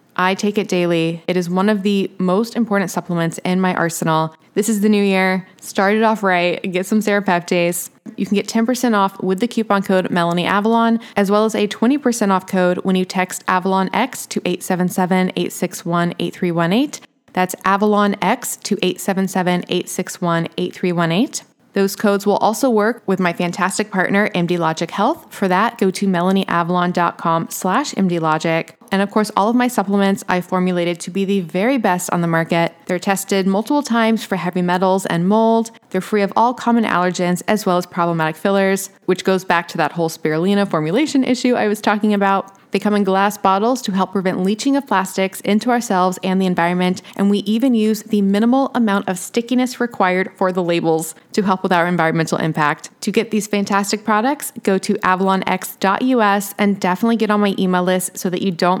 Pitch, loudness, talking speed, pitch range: 195 Hz, -17 LUFS, 185 wpm, 180-215 Hz